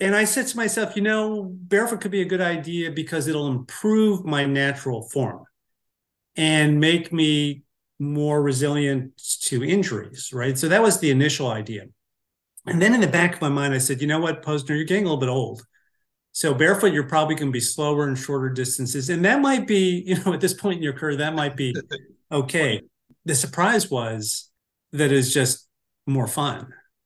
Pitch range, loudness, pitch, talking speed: 135-180 Hz, -22 LUFS, 150 Hz, 195 wpm